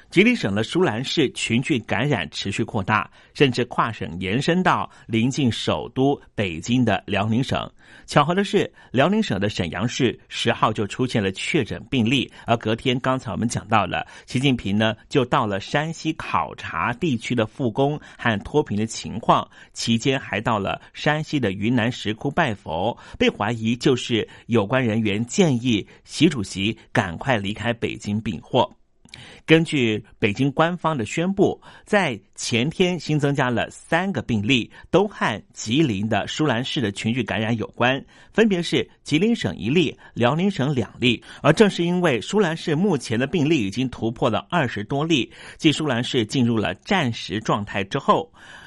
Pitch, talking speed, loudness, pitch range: 120 Hz, 250 characters per minute, -22 LUFS, 110-150 Hz